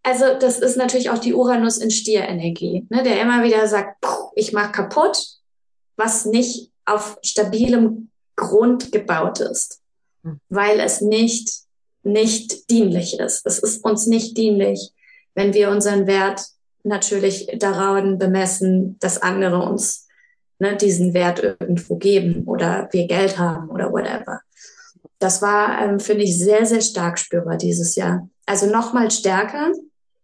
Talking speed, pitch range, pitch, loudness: 145 wpm, 195-230 Hz, 210 Hz, -18 LUFS